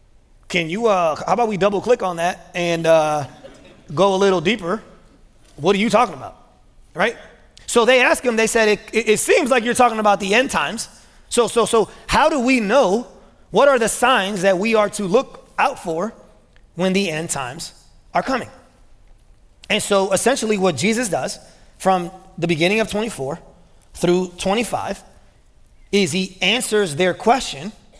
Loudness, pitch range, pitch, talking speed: -18 LUFS, 185-225 Hz, 200 Hz, 175 wpm